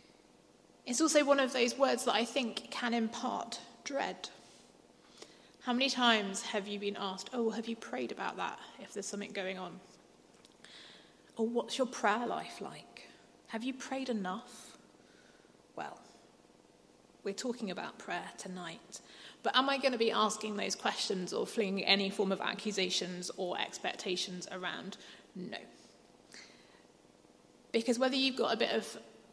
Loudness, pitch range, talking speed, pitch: -34 LUFS, 195-245 Hz, 145 wpm, 225 Hz